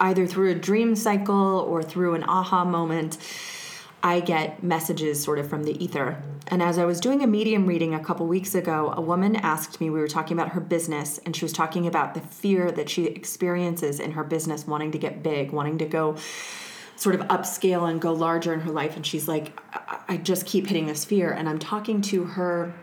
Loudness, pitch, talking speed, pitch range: -25 LUFS, 170 Hz, 220 wpm, 155-185 Hz